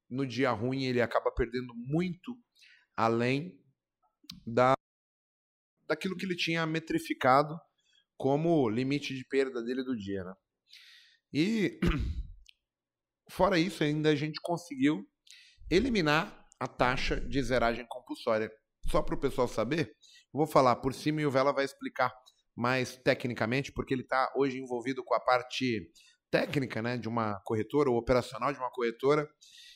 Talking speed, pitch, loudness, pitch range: 140 wpm, 130 Hz, -31 LUFS, 120-155 Hz